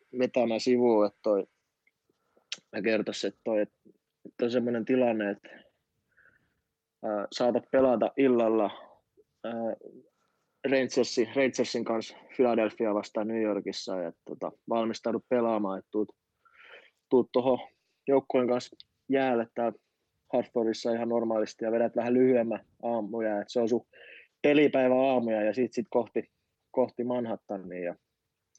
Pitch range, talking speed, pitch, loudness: 110-125 Hz, 120 wpm, 115 Hz, -29 LUFS